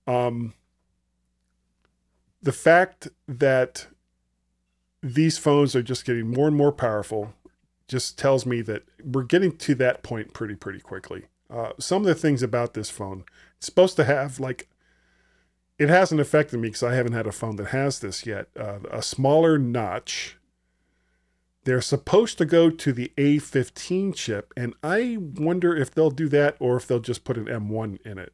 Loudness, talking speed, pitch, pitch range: -23 LUFS, 170 wpm, 125 Hz, 105-150 Hz